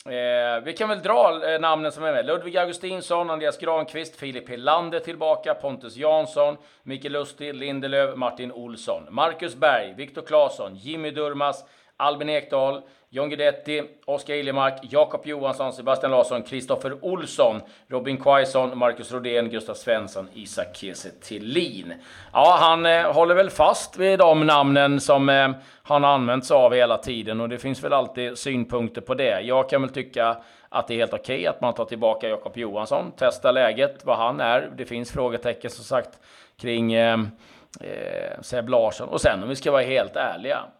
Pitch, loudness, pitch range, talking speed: 140 Hz, -23 LUFS, 125-160 Hz, 170 wpm